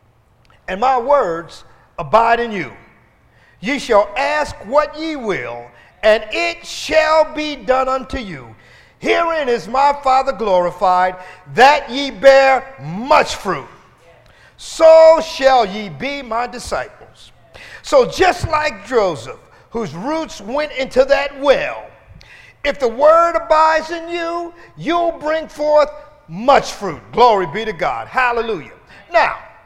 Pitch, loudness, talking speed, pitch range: 265 Hz, -15 LUFS, 125 wpm, 200-300 Hz